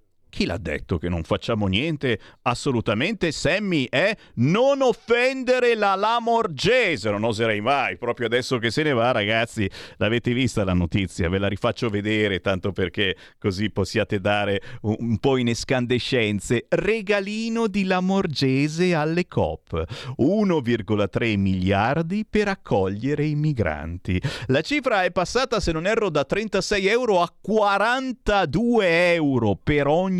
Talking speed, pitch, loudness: 135 wpm, 130 Hz, -22 LUFS